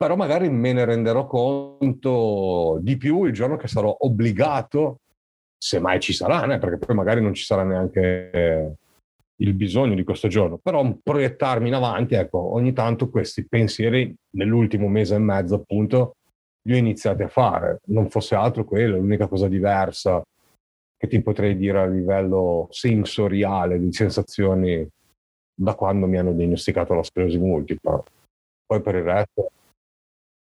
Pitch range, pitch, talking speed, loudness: 95-115 Hz, 105 Hz, 150 wpm, -21 LUFS